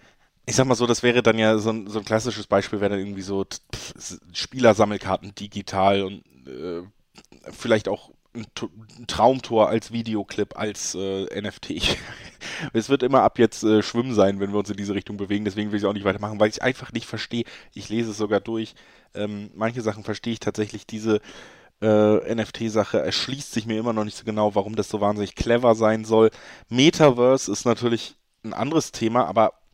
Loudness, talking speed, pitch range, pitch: -23 LUFS, 190 wpm, 100-115 Hz, 110 Hz